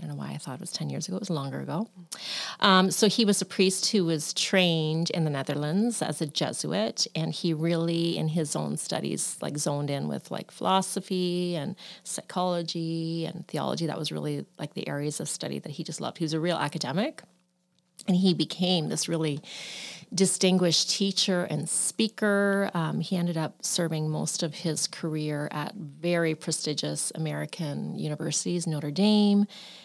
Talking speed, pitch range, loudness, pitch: 180 wpm, 155-190 Hz, -28 LUFS, 170 Hz